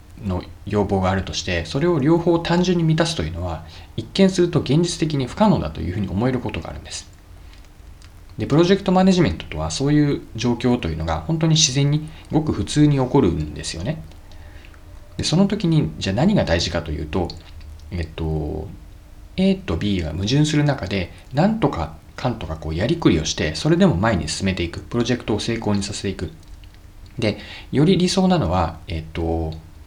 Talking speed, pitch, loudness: 400 characters per minute, 95 Hz, -20 LUFS